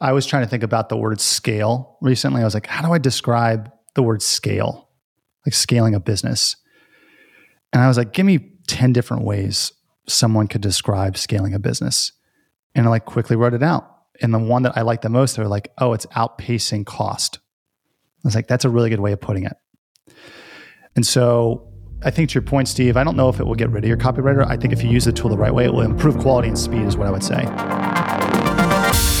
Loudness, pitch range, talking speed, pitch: -18 LUFS, 110-130 Hz, 230 wpm, 115 Hz